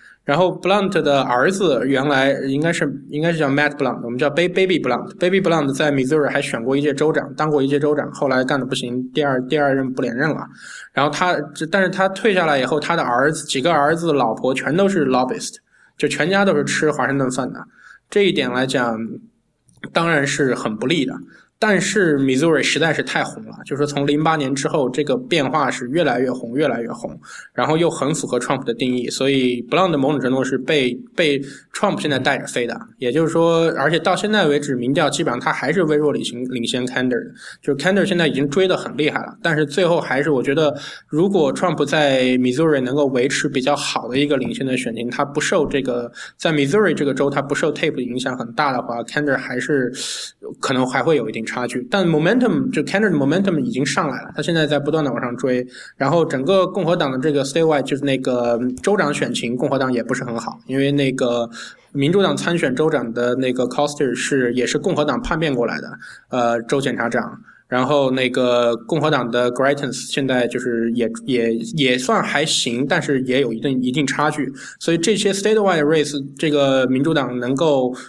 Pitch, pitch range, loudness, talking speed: 140 Hz, 130-155 Hz, -19 LUFS, 405 characters per minute